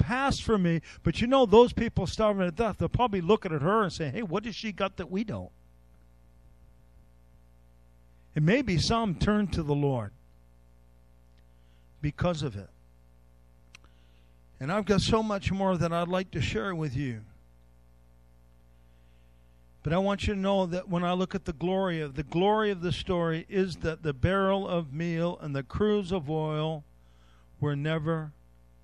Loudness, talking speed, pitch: -28 LUFS, 165 wpm, 155 Hz